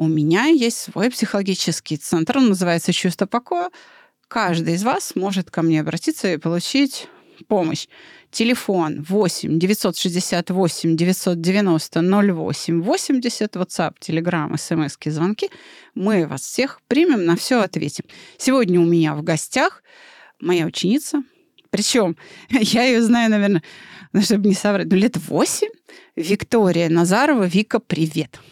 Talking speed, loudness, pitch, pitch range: 125 wpm, -19 LUFS, 195 Hz, 170-240 Hz